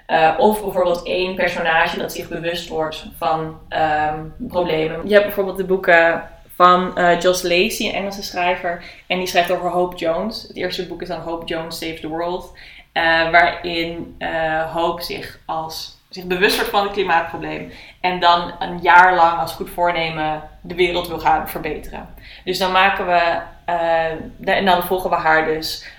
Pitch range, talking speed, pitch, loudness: 165-180 Hz, 180 wpm, 175 Hz, -18 LUFS